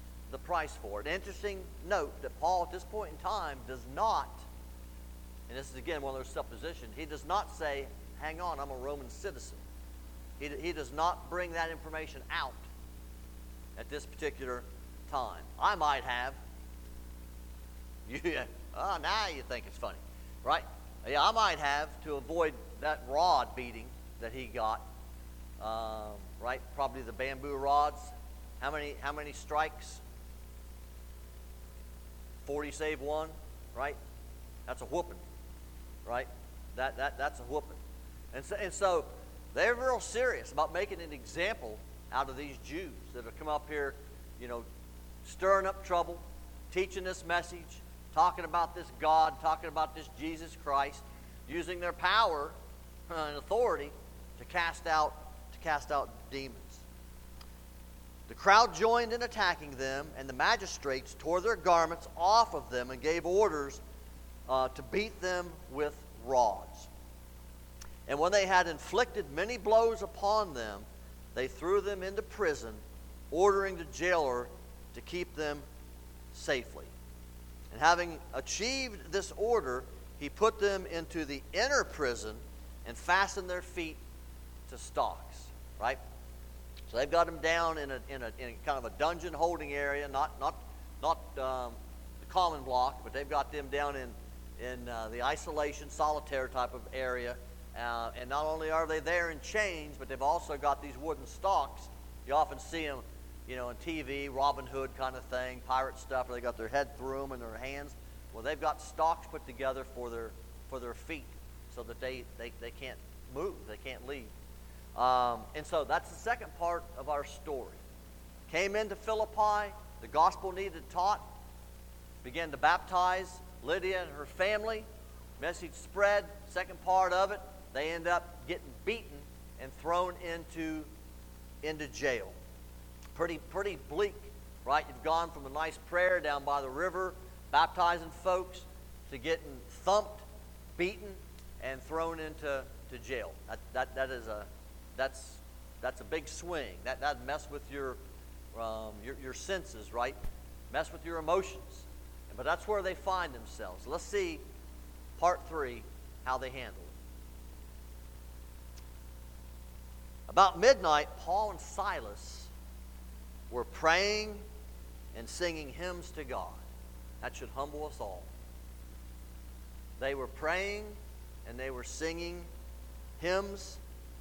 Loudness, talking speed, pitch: -34 LUFS, 150 wpm, 120 Hz